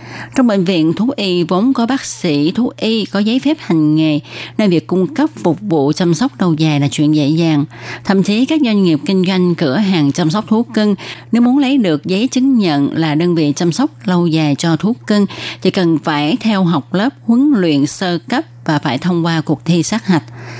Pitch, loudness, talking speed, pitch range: 175 Hz, -14 LUFS, 225 wpm, 155-220 Hz